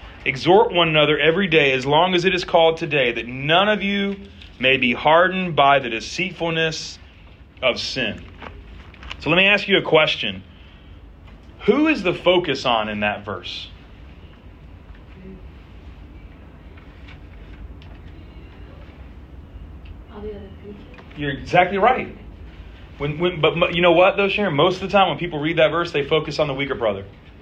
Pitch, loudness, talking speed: 105 Hz, -18 LUFS, 140 wpm